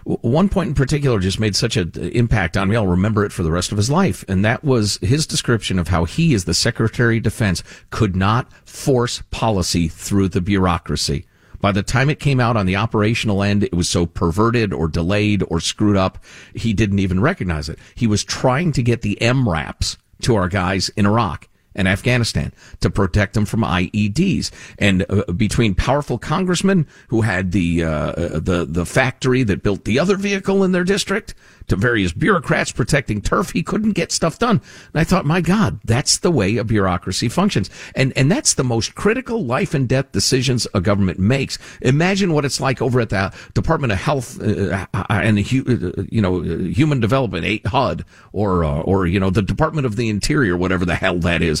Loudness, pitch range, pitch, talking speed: -18 LUFS, 95-130 Hz, 105 Hz, 195 wpm